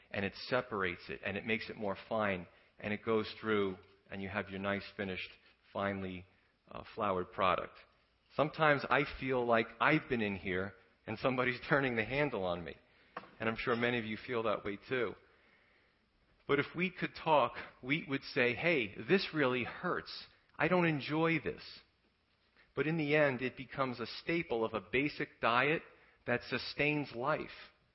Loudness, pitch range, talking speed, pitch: -35 LUFS, 100-145 Hz, 170 wpm, 120 Hz